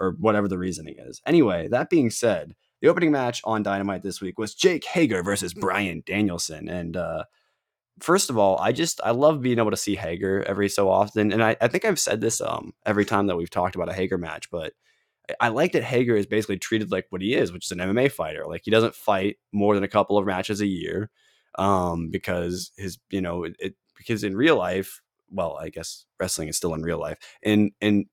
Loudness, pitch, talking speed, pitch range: -24 LUFS, 100 Hz, 230 wpm, 95-110 Hz